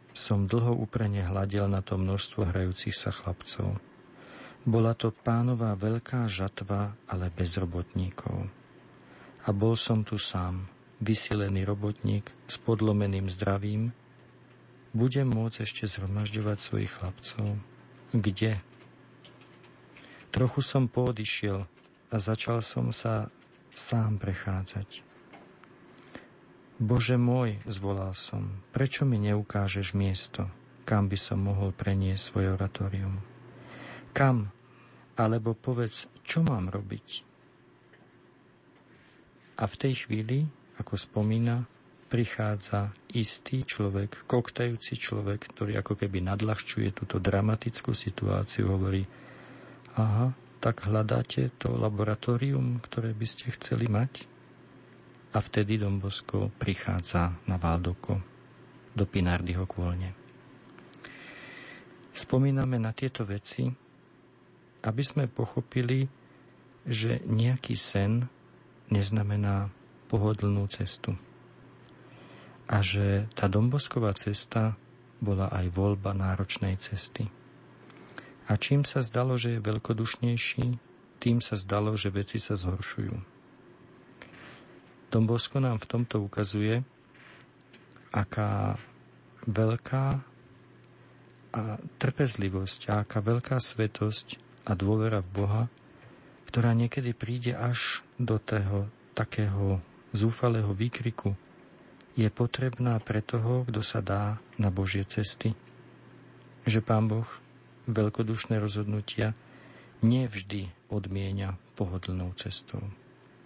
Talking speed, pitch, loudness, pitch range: 95 wpm, 110 Hz, -30 LUFS, 100-120 Hz